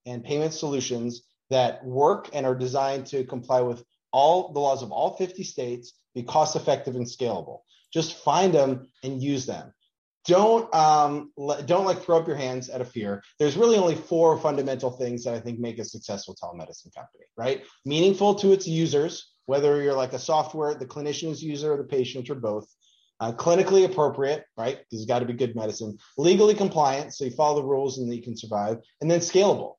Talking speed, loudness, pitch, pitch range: 195 wpm, -25 LUFS, 140 Hz, 125-155 Hz